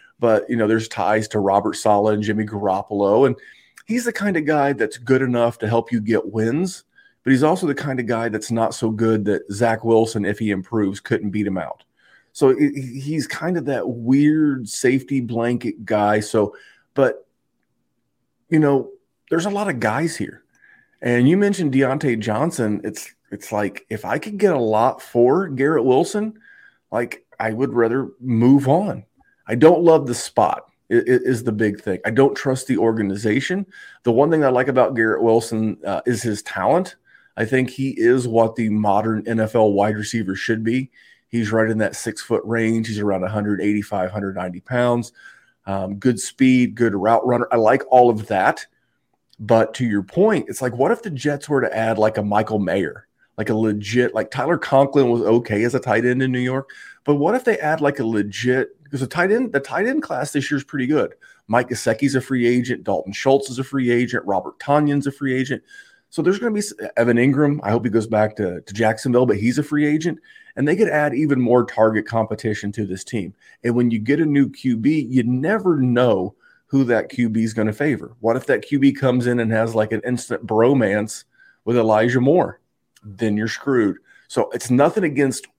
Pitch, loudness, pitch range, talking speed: 120 Hz, -19 LUFS, 110-140 Hz, 200 wpm